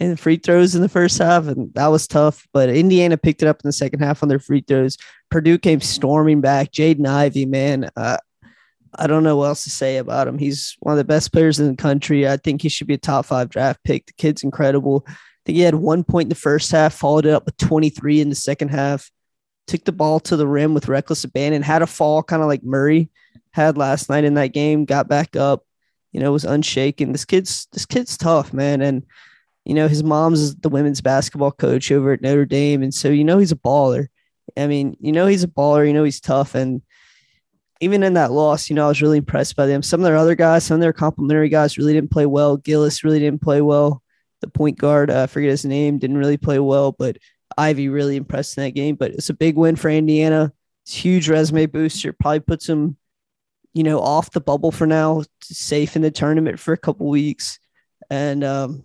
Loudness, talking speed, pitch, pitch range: -17 LUFS, 240 wpm, 150 Hz, 140-155 Hz